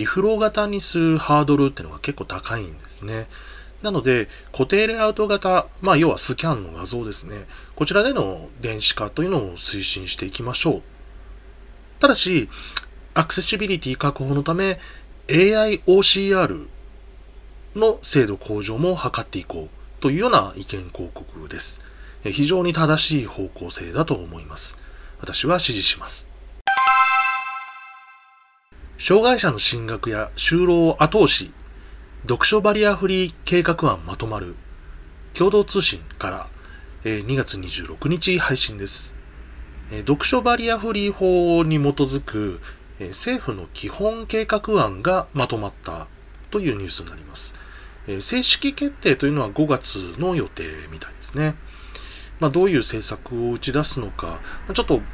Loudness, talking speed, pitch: -20 LUFS, 285 characters per minute, 140 Hz